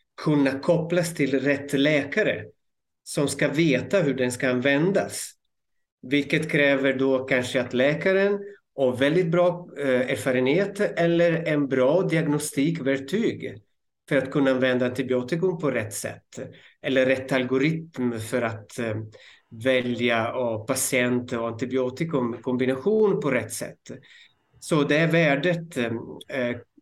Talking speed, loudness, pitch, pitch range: 115 wpm, -24 LUFS, 140 Hz, 130-165 Hz